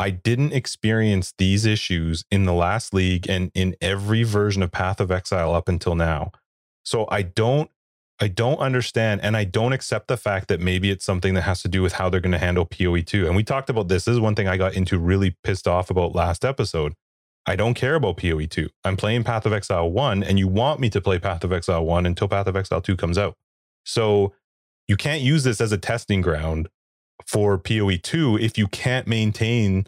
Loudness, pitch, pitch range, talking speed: -22 LUFS, 100 Hz, 90-110 Hz, 215 wpm